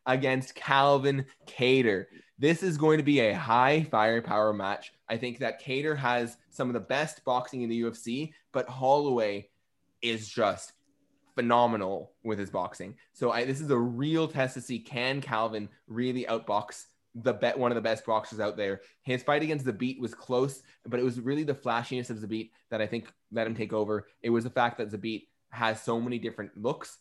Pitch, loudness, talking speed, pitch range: 120 Hz, -29 LUFS, 200 wpm, 110-130 Hz